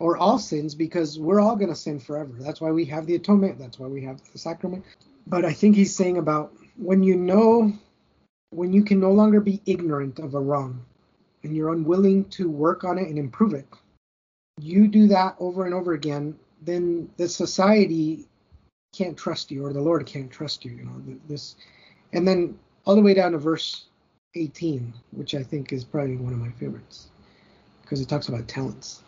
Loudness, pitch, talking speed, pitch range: -23 LUFS, 165 Hz, 200 wpm, 145-190 Hz